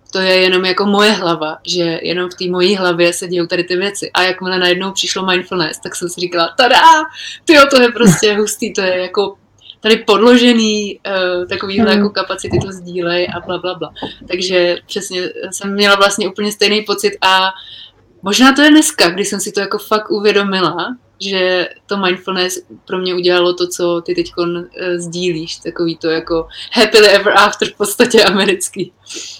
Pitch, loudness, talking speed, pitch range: 190 Hz, -13 LUFS, 180 wpm, 180-205 Hz